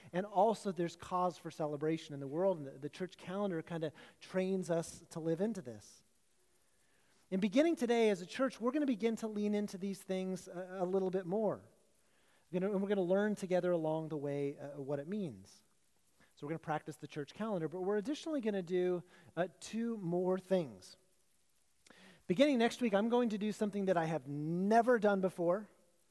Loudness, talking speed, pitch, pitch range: -37 LUFS, 205 wpm, 185 Hz, 165-205 Hz